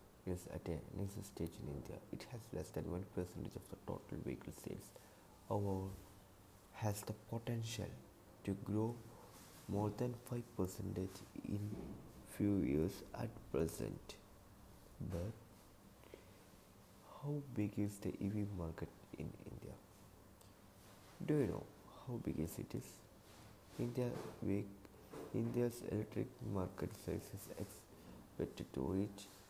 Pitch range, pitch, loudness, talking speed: 95-110 Hz, 100 Hz, -45 LUFS, 120 wpm